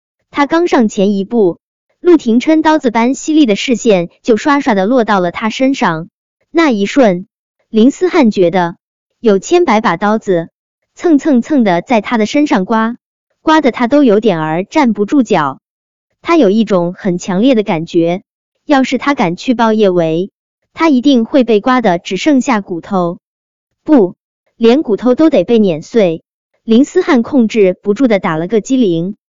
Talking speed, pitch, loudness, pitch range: 235 characters per minute, 230 Hz, -11 LUFS, 195-275 Hz